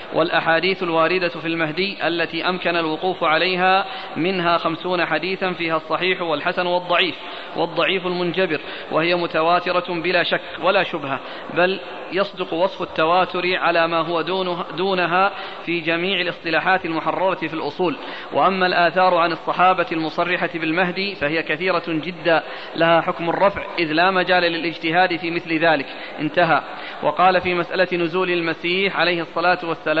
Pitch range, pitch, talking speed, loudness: 165-180 Hz, 175 Hz, 130 wpm, -20 LUFS